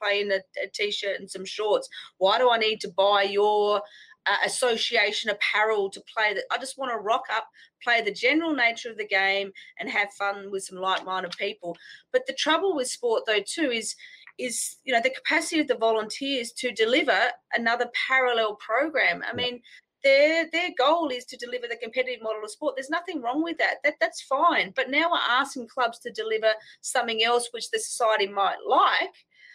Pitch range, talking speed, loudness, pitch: 210-275 Hz, 195 wpm, -25 LUFS, 240 Hz